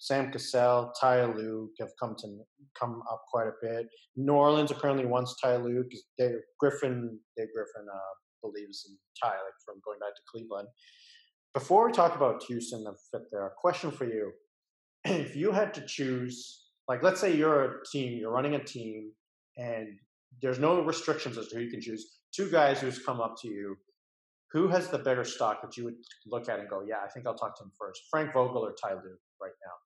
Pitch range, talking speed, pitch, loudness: 115-145 Hz, 210 wpm, 125 Hz, -31 LUFS